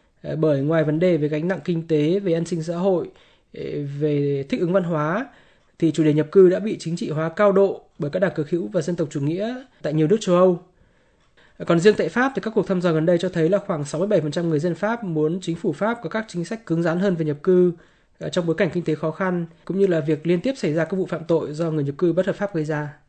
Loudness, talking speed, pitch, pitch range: -22 LUFS, 280 wpm, 175 Hz, 155-190 Hz